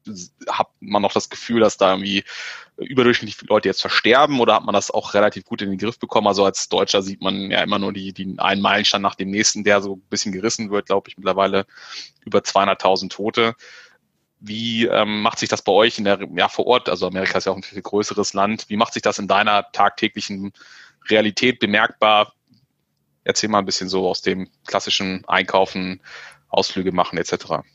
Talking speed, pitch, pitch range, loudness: 200 wpm, 100 Hz, 95-110 Hz, -19 LUFS